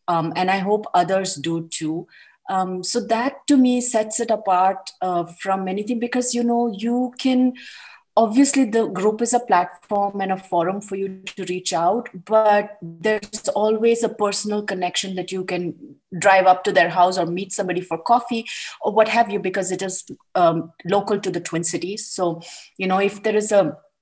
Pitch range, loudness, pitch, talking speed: 180-220 Hz, -20 LUFS, 195 Hz, 190 wpm